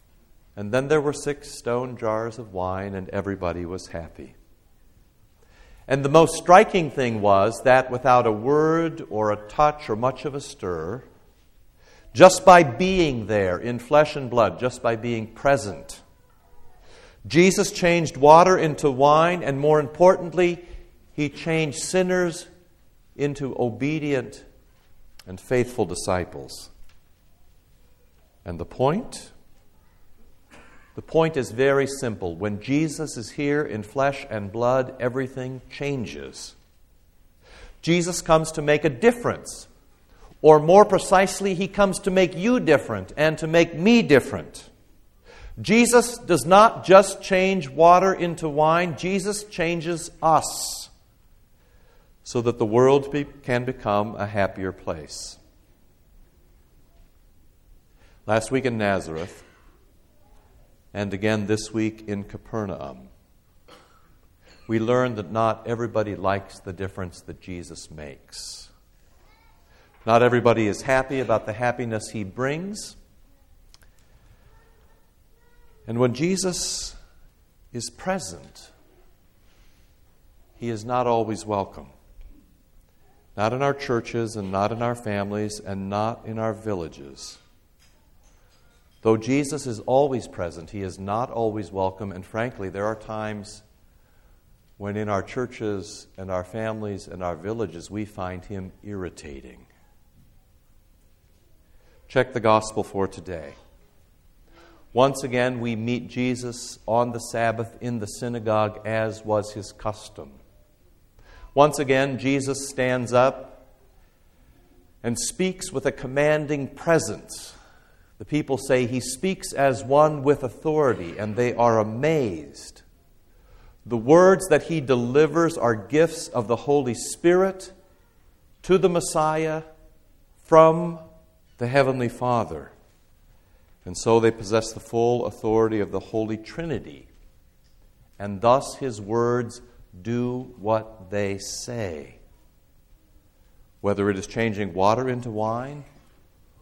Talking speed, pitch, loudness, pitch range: 120 wpm, 115 Hz, -22 LUFS, 100-145 Hz